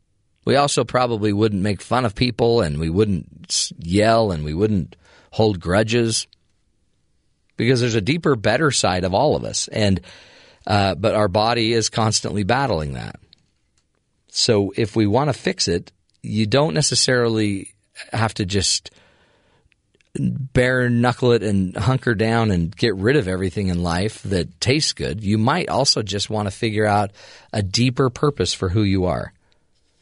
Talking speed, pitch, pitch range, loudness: 160 wpm, 110 Hz, 100-120 Hz, -20 LUFS